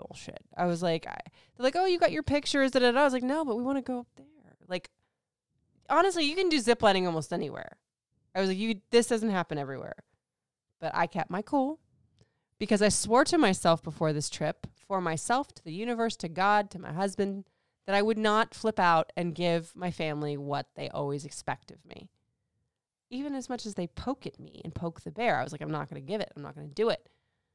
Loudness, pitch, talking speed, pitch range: -29 LUFS, 195 Hz, 225 wpm, 165-245 Hz